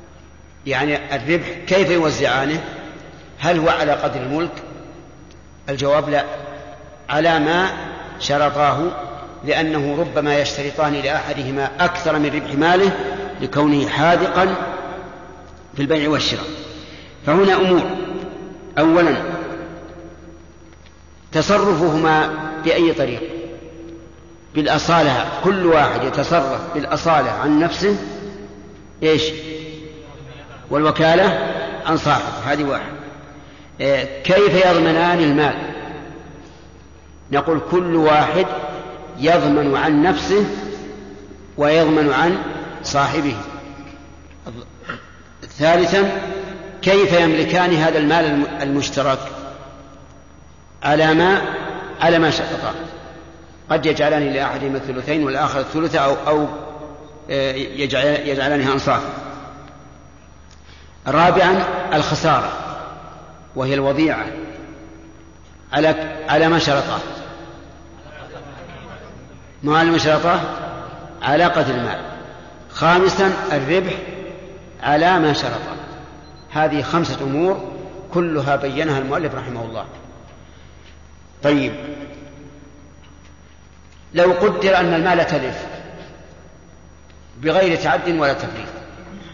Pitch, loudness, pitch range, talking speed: 150 Hz, -18 LUFS, 135-165 Hz, 80 wpm